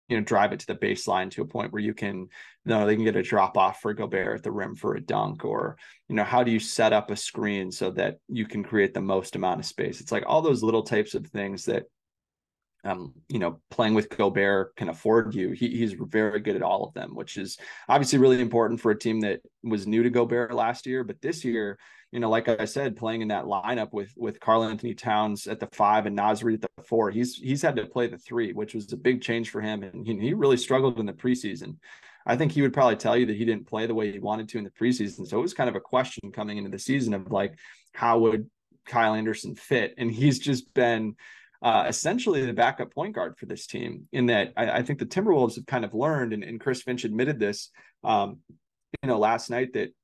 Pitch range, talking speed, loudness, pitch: 105-120 Hz, 250 wpm, -26 LUFS, 110 Hz